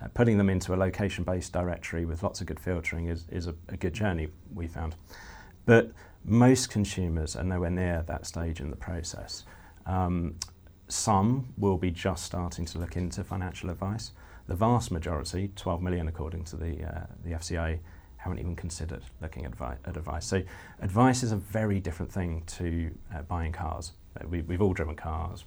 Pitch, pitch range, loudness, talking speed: 90 Hz, 85-95 Hz, -31 LUFS, 175 wpm